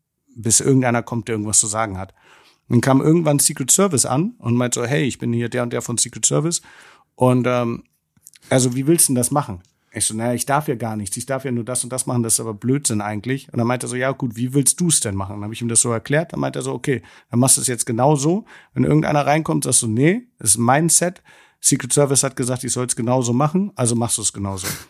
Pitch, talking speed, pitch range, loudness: 125 Hz, 275 wpm, 115-145 Hz, -18 LUFS